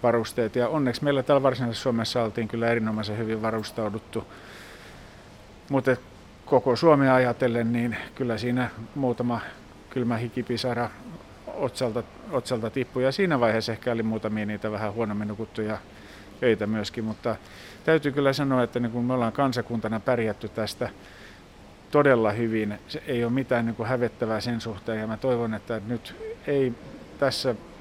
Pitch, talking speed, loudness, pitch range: 115 Hz, 140 wpm, -26 LUFS, 110-125 Hz